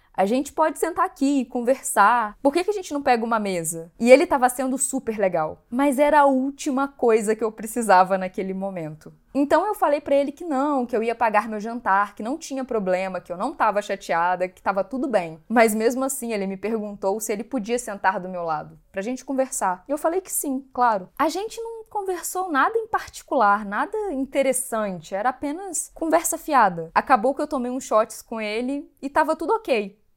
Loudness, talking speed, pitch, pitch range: -23 LUFS, 210 wpm, 250 Hz, 205-285 Hz